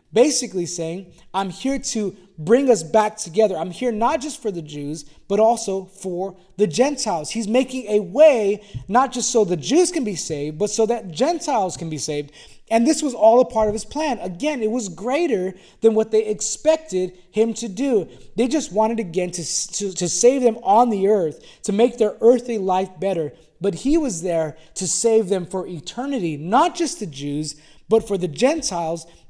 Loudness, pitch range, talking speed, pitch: -20 LUFS, 180-240 Hz, 195 wpm, 210 Hz